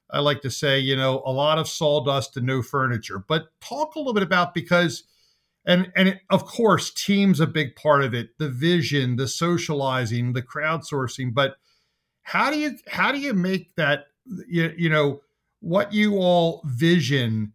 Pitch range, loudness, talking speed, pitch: 135-180 Hz, -22 LUFS, 180 wpm, 155 Hz